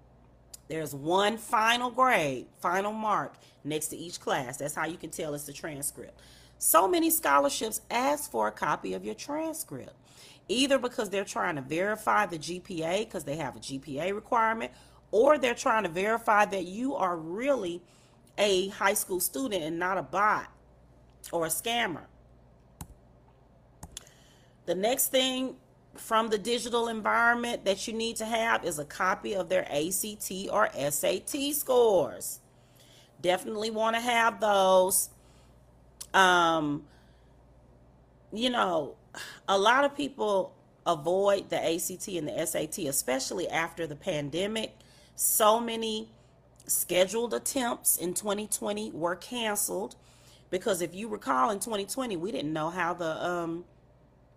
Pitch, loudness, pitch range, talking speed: 190 Hz, -28 LUFS, 160-225 Hz, 140 wpm